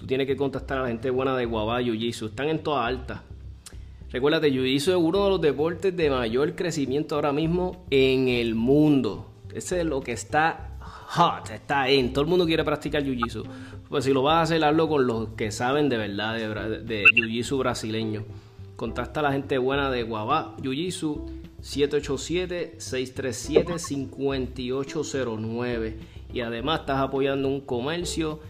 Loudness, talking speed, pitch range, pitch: -25 LUFS, 170 wpm, 115-150 Hz, 130 Hz